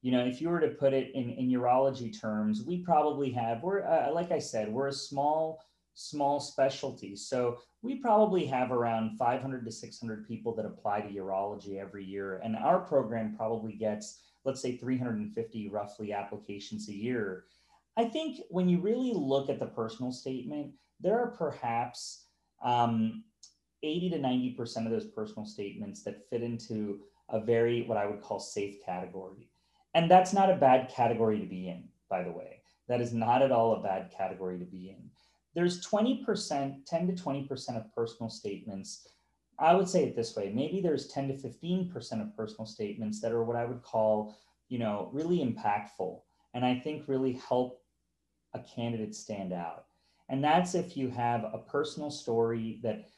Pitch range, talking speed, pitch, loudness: 110-140 Hz, 180 wpm, 120 Hz, -32 LUFS